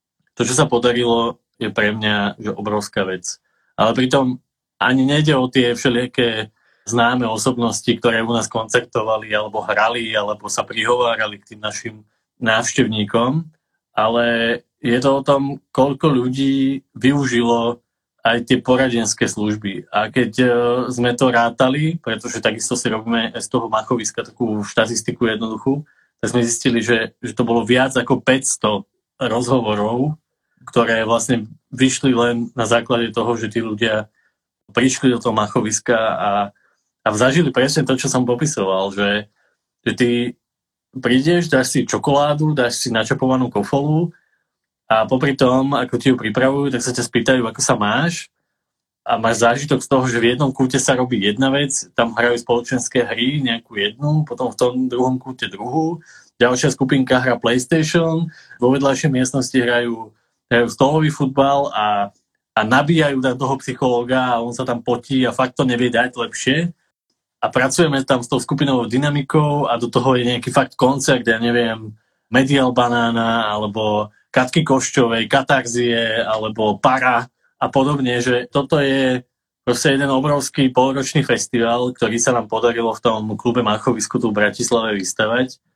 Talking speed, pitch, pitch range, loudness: 150 wpm, 125 Hz, 115-135 Hz, -18 LUFS